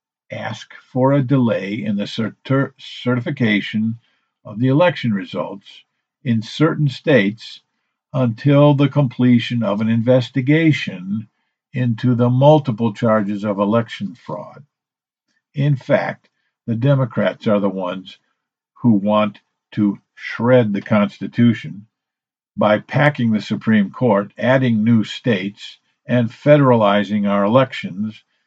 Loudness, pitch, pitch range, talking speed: -17 LUFS, 120 Hz, 105-135 Hz, 110 wpm